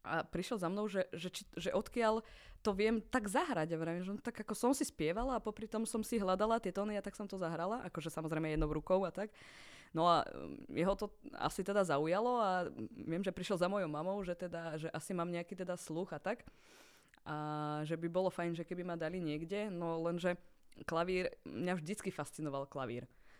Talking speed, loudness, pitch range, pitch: 205 wpm, -39 LUFS, 165-205 Hz, 180 Hz